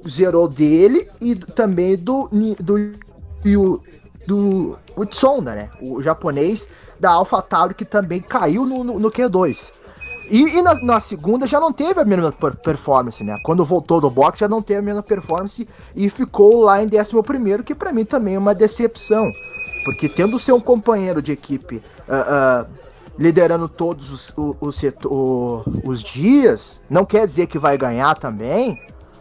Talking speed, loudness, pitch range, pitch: 165 wpm, -17 LUFS, 150-225 Hz, 195 Hz